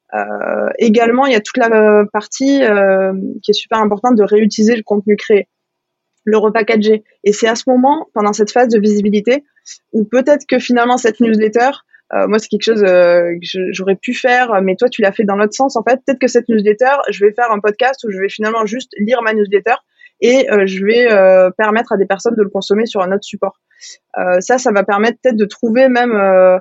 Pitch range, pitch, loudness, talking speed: 205-245 Hz, 220 Hz, -13 LUFS, 225 wpm